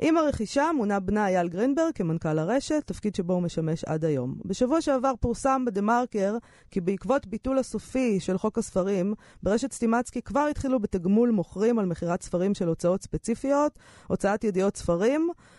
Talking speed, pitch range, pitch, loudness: 155 wpm, 185-260 Hz, 215 Hz, -27 LUFS